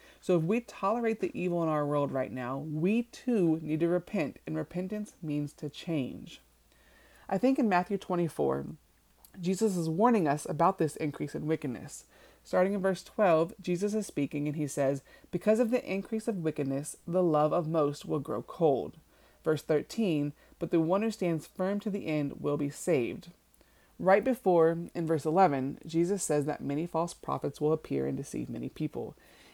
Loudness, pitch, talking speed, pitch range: -31 LUFS, 165 Hz, 180 wpm, 150-195 Hz